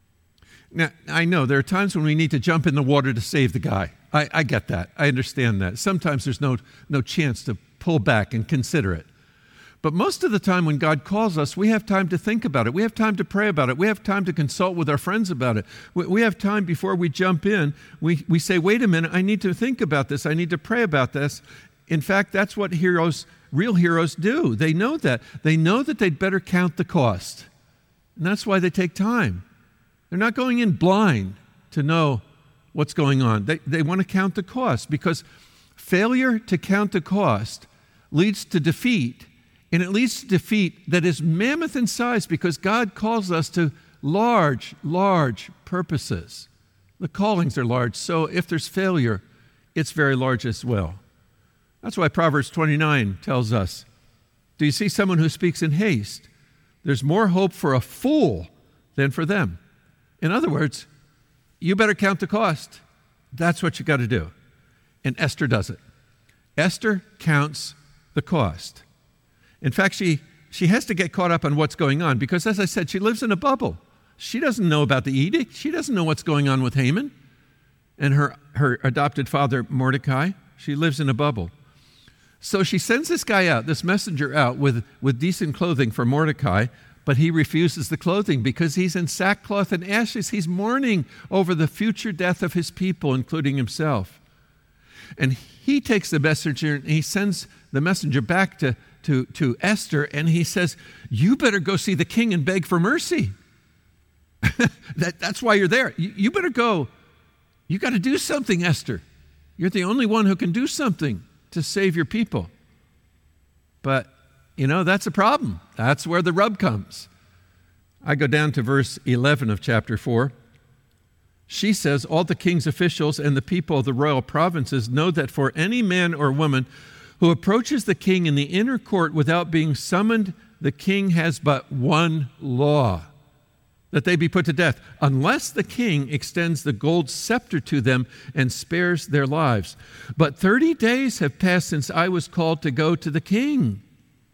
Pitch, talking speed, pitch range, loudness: 160 Hz, 185 wpm, 135-190 Hz, -22 LUFS